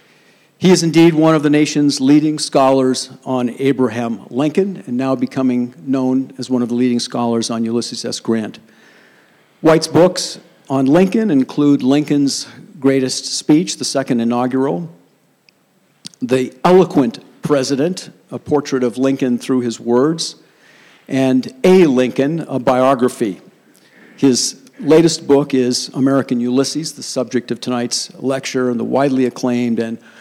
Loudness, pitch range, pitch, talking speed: -16 LUFS, 125-150 Hz, 135 Hz, 135 wpm